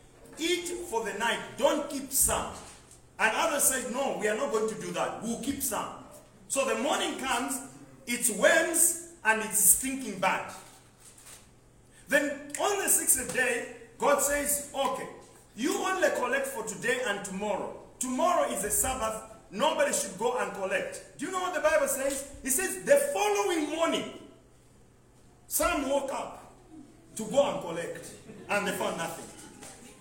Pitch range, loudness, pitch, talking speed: 230-315 Hz, -28 LUFS, 275 Hz, 155 wpm